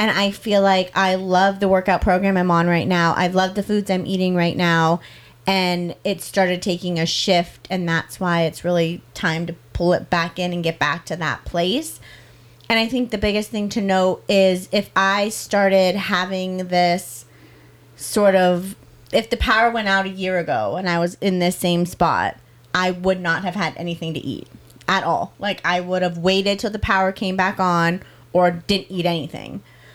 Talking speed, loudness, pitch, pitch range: 200 wpm, -20 LUFS, 180 Hz, 170-190 Hz